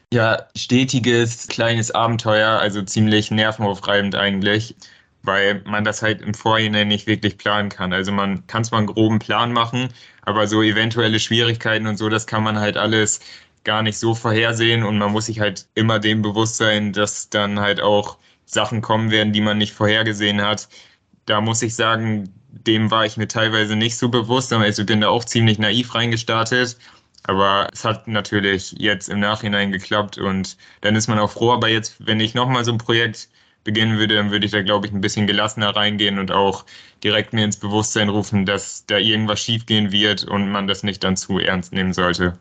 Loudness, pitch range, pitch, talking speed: -18 LUFS, 105-110 Hz, 110 Hz, 195 wpm